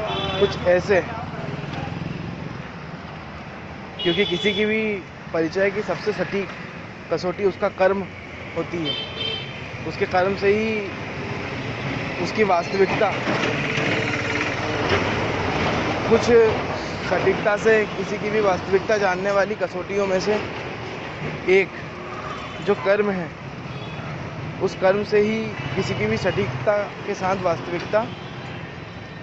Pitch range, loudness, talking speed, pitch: 160-200 Hz, -22 LUFS, 100 wpm, 180 Hz